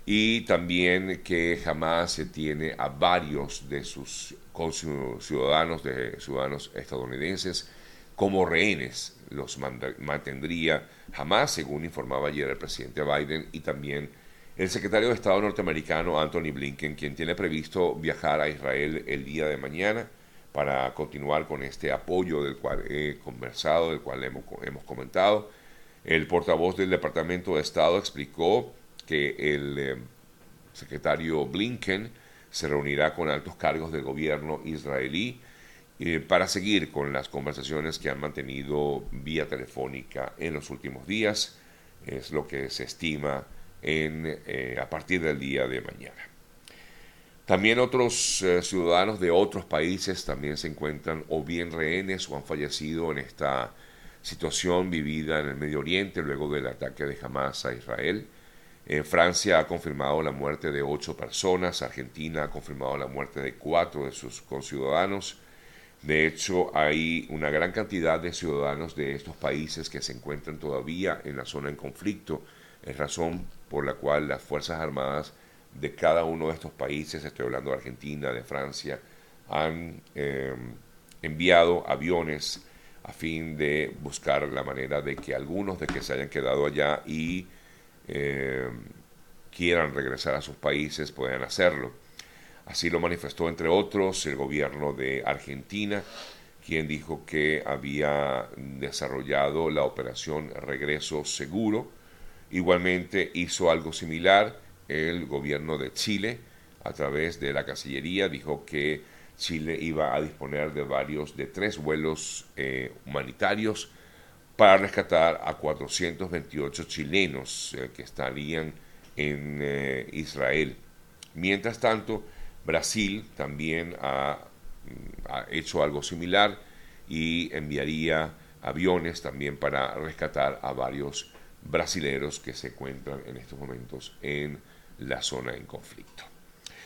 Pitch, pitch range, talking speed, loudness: 75 Hz, 70-85 Hz, 135 wpm, -29 LUFS